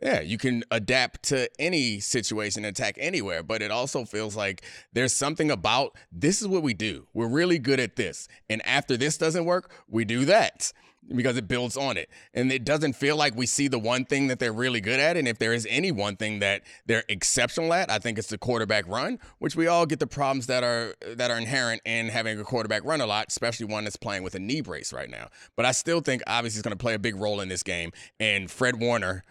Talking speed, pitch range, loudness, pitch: 240 wpm, 110-135 Hz, -26 LUFS, 120 Hz